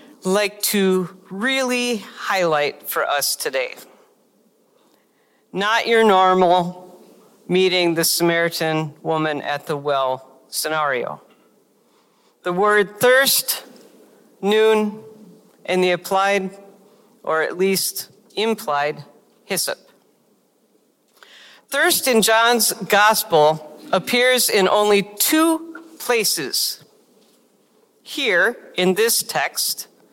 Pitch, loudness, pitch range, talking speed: 200 Hz, -18 LUFS, 175-225 Hz, 85 wpm